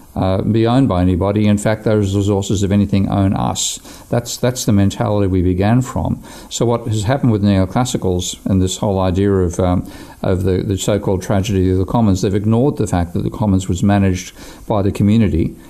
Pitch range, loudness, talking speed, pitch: 95-110 Hz, -16 LUFS, 205 wpm, 100 Hz